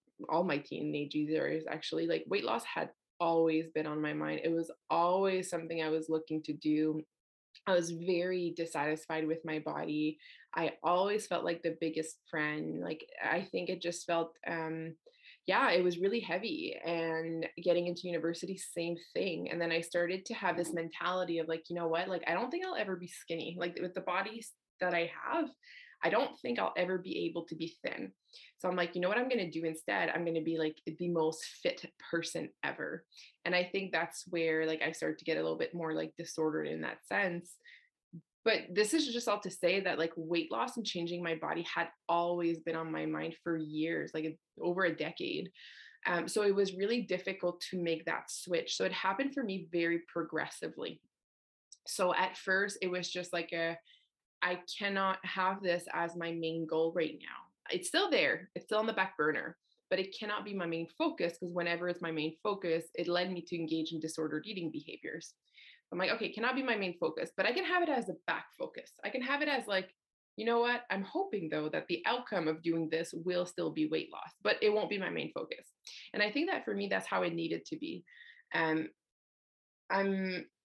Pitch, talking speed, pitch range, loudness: 175 Hz, 215 wpm, 165-190 Hz, -35 LUFS